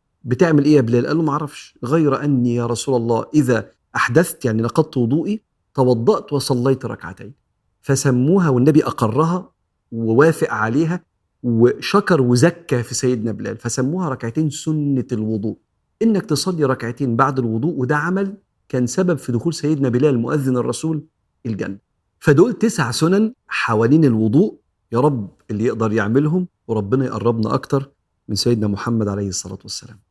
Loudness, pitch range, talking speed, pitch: -18 LUFS, 115-155 Hz, 140 wpm, 130 Hz